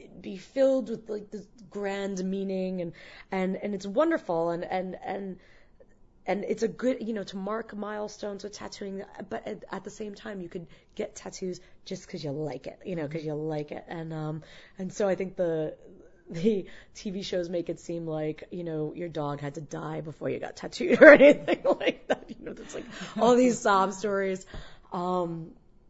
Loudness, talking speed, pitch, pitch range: -27 LUFS, 195 wpm, 190 Hz, 170-210 Hz